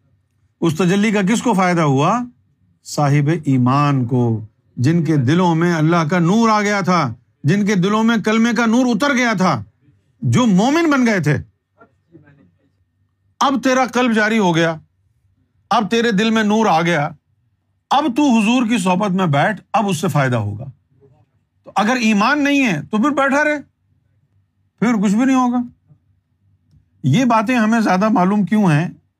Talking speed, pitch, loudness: 165 wpm, 175 Hz, -16 LUFS